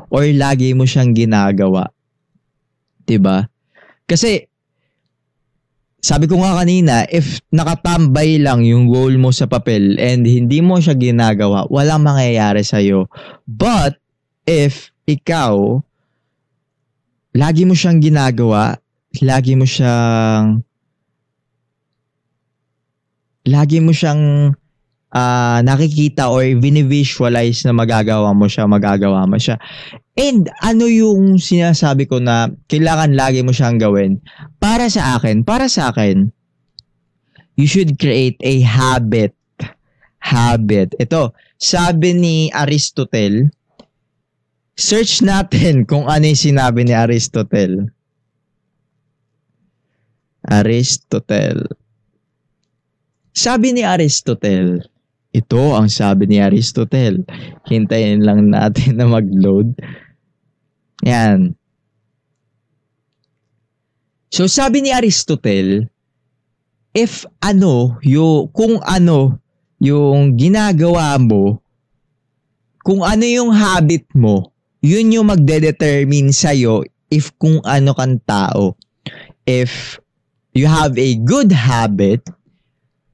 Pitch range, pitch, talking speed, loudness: 115-155 Hz, 135 Hz, 95 wpm, -13 LUFS